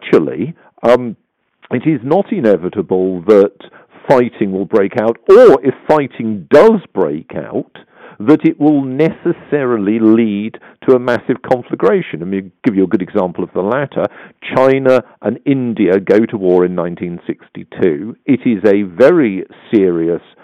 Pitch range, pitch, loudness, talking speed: 95-140 Hz, 115 Hz, -13 LUFS, 165 wpm